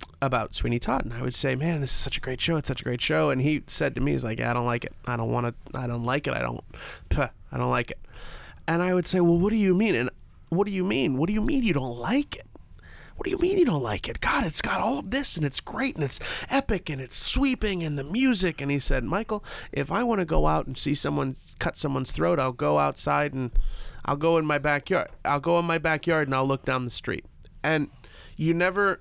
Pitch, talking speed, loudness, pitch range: 145 Hz, 275 wpm, -26 LUFS, 130-185 Hz